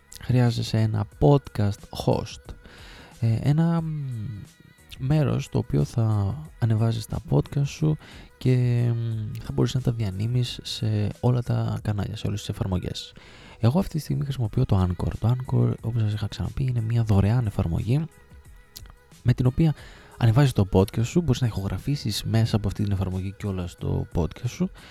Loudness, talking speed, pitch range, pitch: -25 LUFS, 155 wpm, 100-130 Hz, 115 Hz